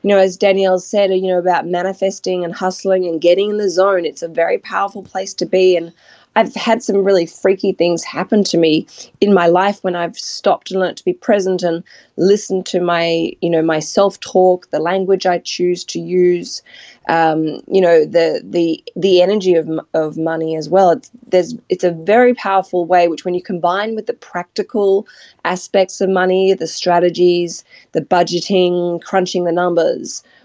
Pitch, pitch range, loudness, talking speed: 185 Hz, 175-195 Hz, -15 LUFS, 185 wpm